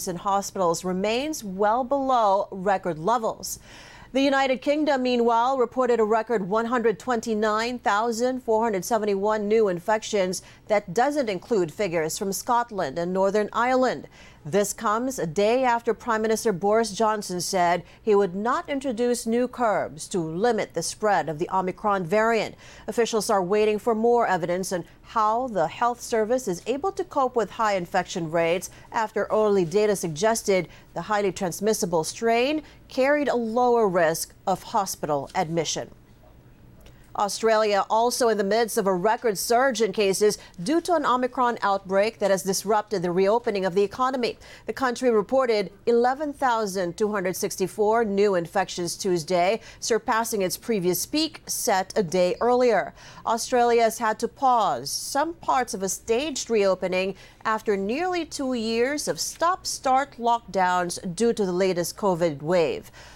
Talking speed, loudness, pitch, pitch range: 140 wpm, -24 LUFS, 215 Hz, 190-240 Hz